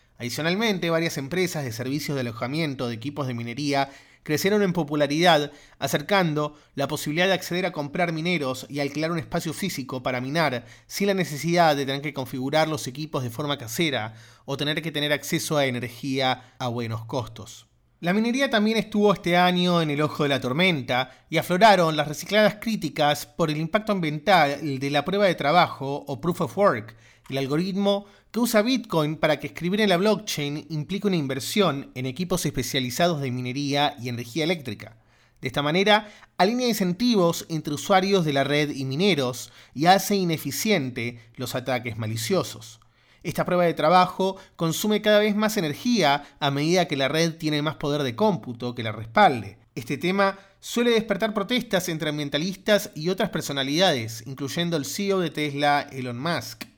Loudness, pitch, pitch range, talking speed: -24 LUFS, 150 Hz, 135-180 Hz, 170 wpm